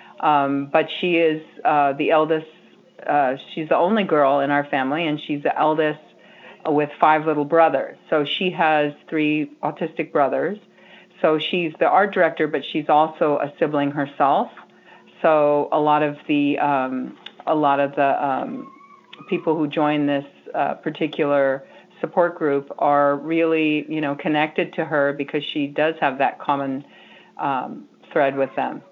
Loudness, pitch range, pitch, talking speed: -21 LUFS, 145-160 Hz, 150 Hz, 160 wpm